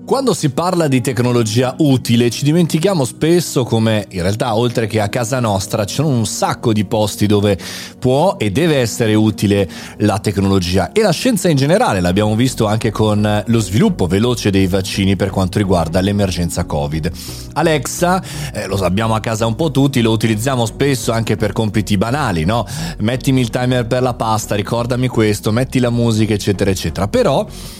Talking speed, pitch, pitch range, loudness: 175 wpm, 115 Hz, 100-130 Hz, -15 LUFS